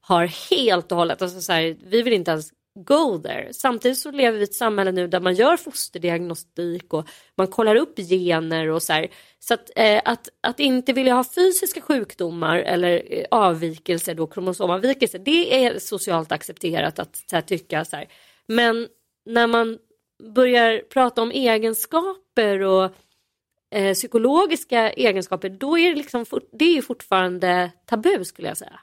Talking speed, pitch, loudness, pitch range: 160 wpm, 220 Hz, -21 LUFS, 180-255 Hz